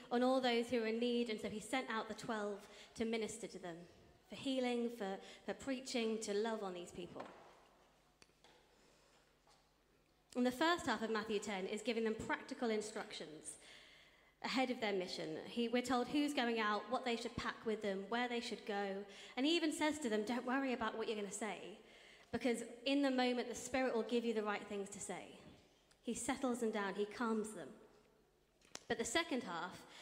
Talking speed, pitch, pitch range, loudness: 200 wpm, 225 Hz, 210-245 Hz, -41 LUFS